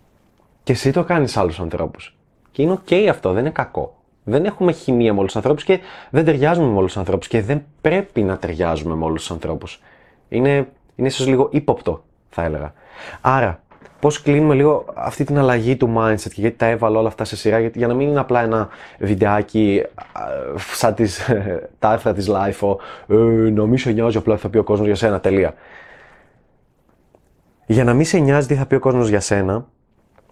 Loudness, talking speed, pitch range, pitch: -18 LUFS, 195 wpm, 105-140 Hz, 115 Hz